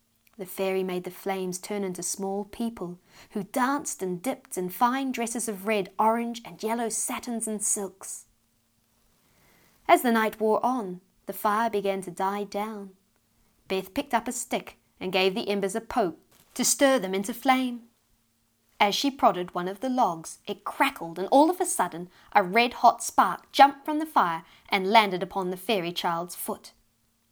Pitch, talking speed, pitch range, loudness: 205 Hz, 175 wpm, 185-235 Hz, -26 LUFS